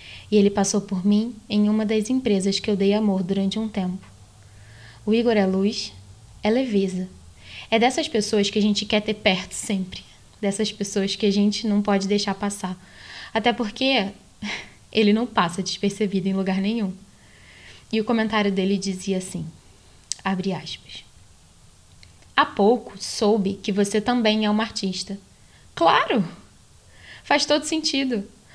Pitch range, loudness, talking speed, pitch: 185-215 Hz, -23 LUFS, 150 wpm, 200 Hz